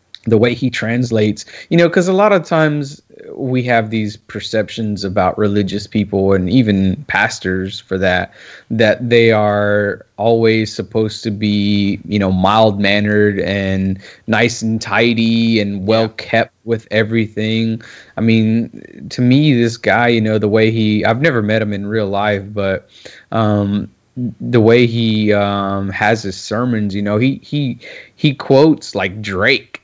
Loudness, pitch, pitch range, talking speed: -15 LUFS, 110 Hz, 100-115 Hz, 155 wpm